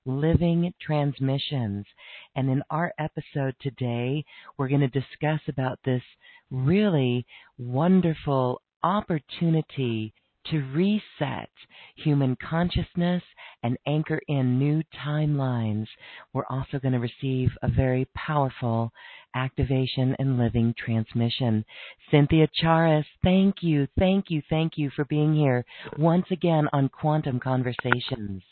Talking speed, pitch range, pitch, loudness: 110 wpm, 125-155 Hz, 135 Hz, -26 LUFS